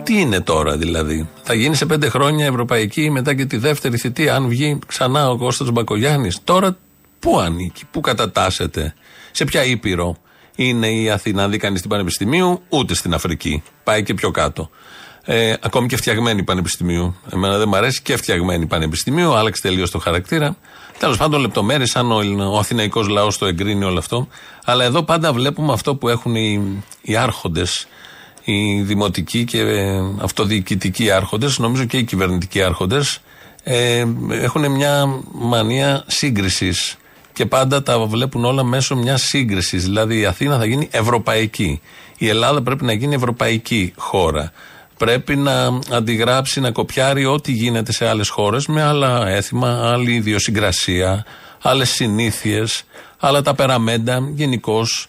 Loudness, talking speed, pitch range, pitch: -17 LUFS, 150 wpm, 100-130 Hz, 115 Hz